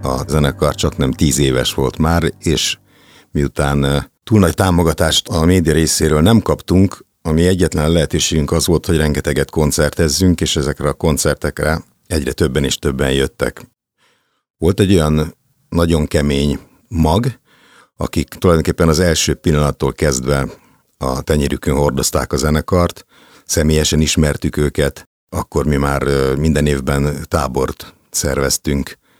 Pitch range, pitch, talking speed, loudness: 70-85 Hz, 75 Hz, 125 wpm, -16 LUFS